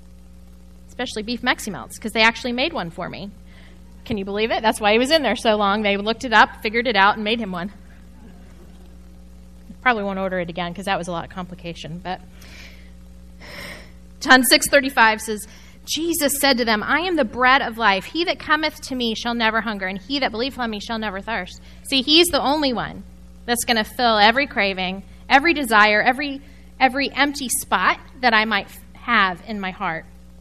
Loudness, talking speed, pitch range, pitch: -19 LUFS, 200 wpm, 170-255 Hz, 215 Hz